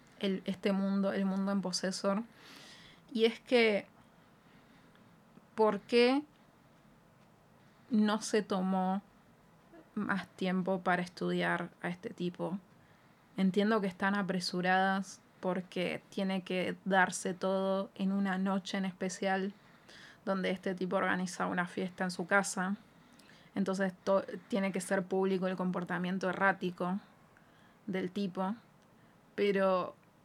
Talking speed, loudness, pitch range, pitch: 115 wpm, -33 LUFS, 185-200 Hz, 195 Hz